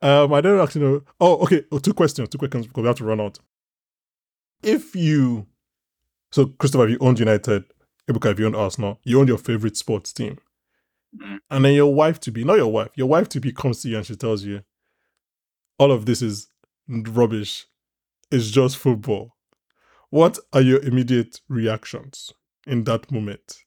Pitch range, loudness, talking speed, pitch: 110-140 Hz, -20 LUFS, 185 wpm, 125 Hz